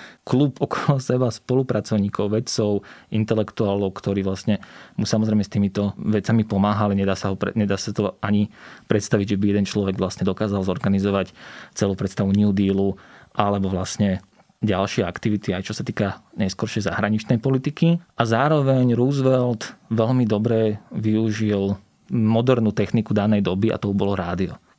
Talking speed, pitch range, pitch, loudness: 135 wpm, 100-115 Hz, 105 Hz, -22 LUFS